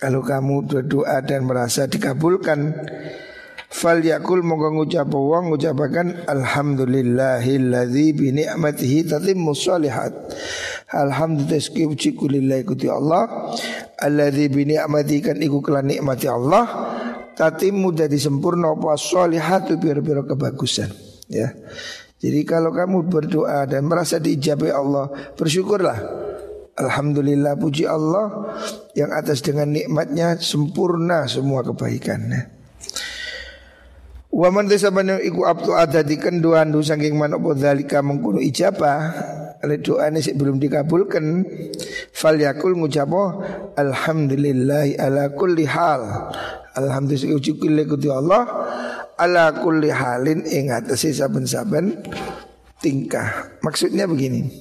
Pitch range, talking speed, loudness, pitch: 140-165 Hz, 110 wpm, -20 LUFS, 150 Hz